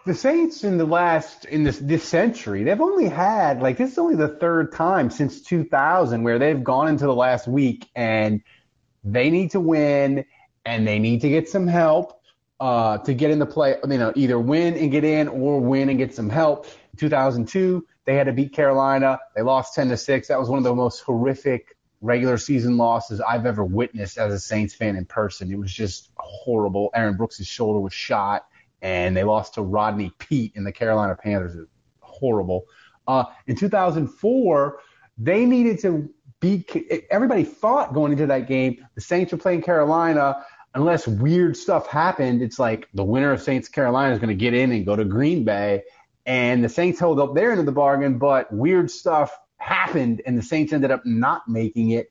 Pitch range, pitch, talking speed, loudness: 115-155 Hz, 130 Hz, 200 wpm, -21 LUFS